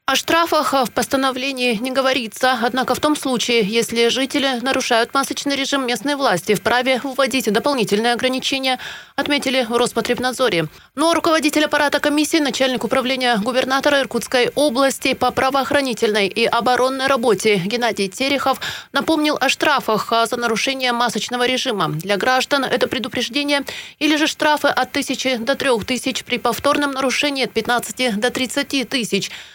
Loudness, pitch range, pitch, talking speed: -18 LUFS, 240-275 Hz, 260 Hz, 135 wpm